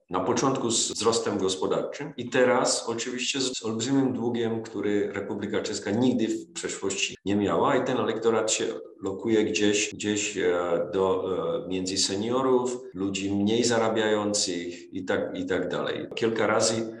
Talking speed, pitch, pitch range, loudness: 140 wpm, 110 Hz, 100-120 Hz, -26 LUFS